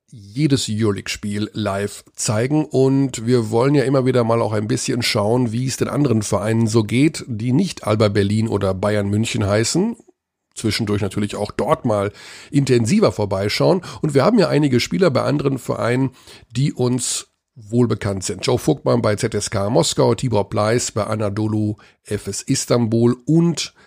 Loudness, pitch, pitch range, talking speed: -19 LUFS, 115 Hz, 105-130 Hz, 160 wpm